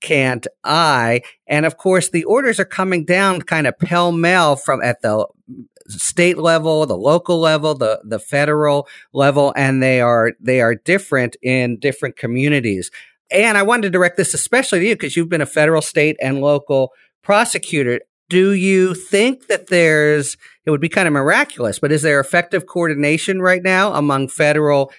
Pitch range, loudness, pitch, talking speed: 140-185 Hz, -15 LUFS, 155 Hz, 175 wpm